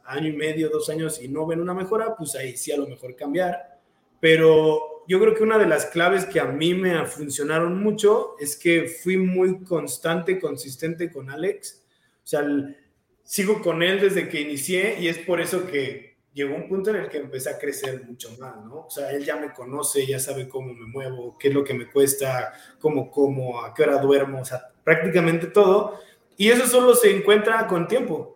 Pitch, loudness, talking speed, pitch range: 155 Hz, -22 LUFS, 210 wpm, 140-185 Hz